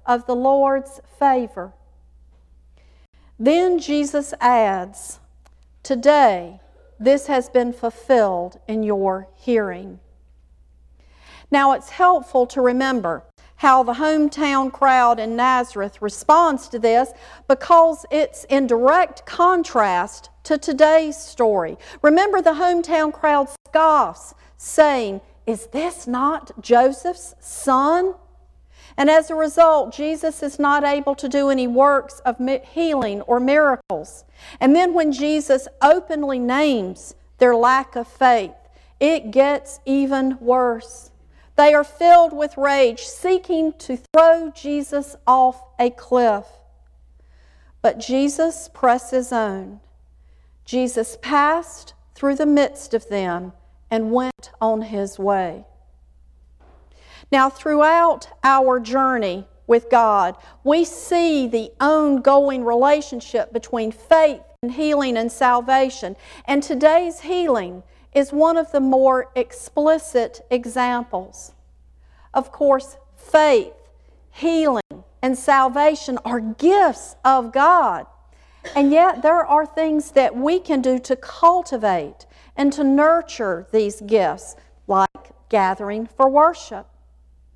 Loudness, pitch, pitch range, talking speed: -18 LUFS, 265 Hz, 225-300 Hz, 110 wpm